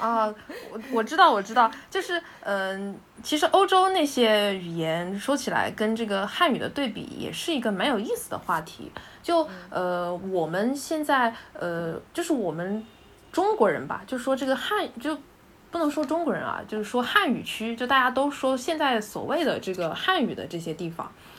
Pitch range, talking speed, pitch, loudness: 200-310 Hz, 270 characters per minute, 245 Hz, -26 LUFS